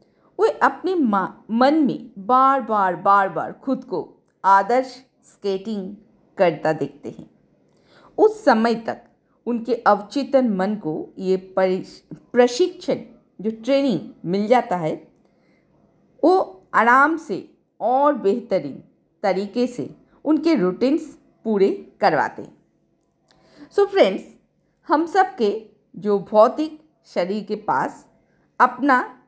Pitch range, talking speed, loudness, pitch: 200-275 Hz, 110 wpm, -20 LUFS, 235 Hz